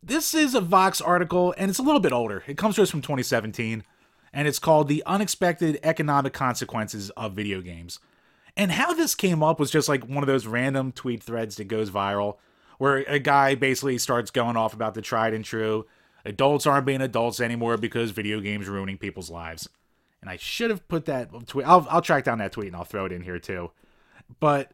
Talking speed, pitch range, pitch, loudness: 215 wpm, 110-155 Hz, 130 Hz, -24 LUFS